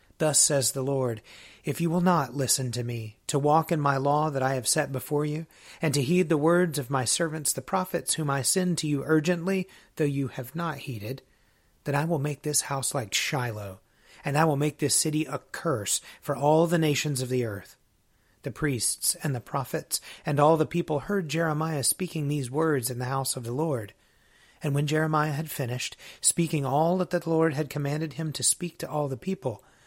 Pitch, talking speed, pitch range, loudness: 150 Hz, 210 wpm, 135-160 Hz, -27 LUFS